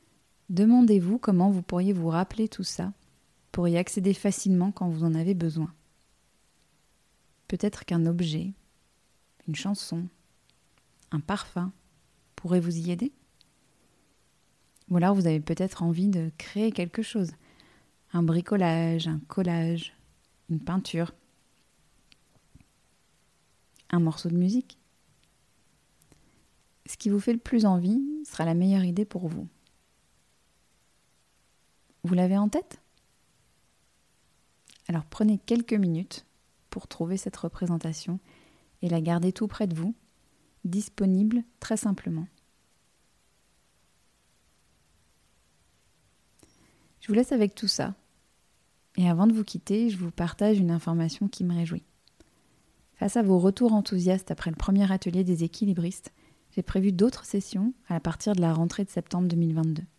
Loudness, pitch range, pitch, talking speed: -27 LUFS, 165-205 Hz, 180 Hz, 125 wpm